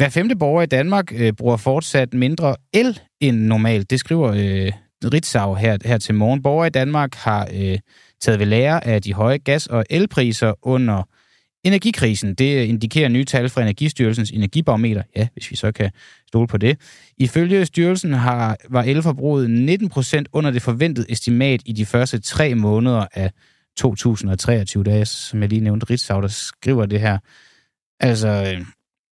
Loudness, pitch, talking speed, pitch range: -18 LUFS, 120 Hz, 170 wpm, 110-140 Hz